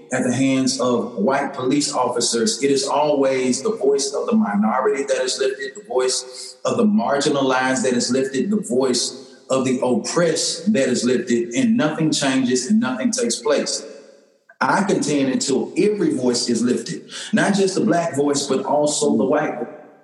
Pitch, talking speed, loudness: 145 Hz, 170 wpm, -19 LUFS